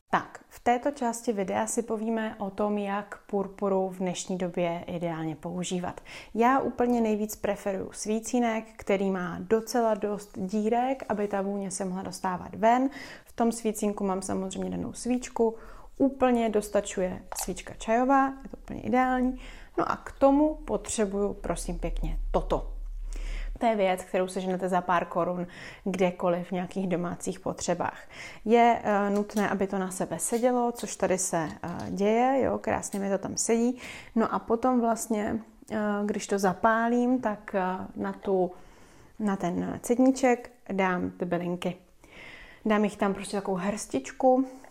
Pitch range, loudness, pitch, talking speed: 185-230 Hz, -28 LUFS, 205 Hz, 145 wpm